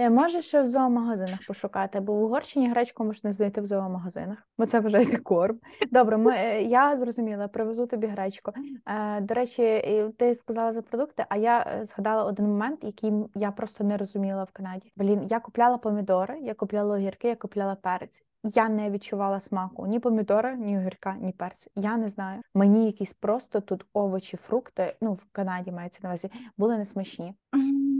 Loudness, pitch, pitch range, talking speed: -27 LUFS, 215 Hz, 200-235 Hz, 170 wpm